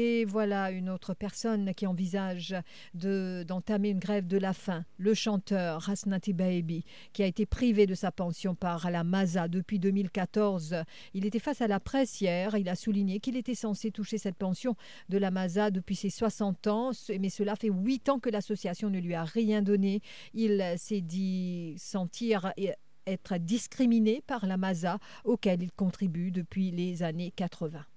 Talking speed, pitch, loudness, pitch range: 175 wpm, 195 Hz, -31 LUFS, 185-210 Hz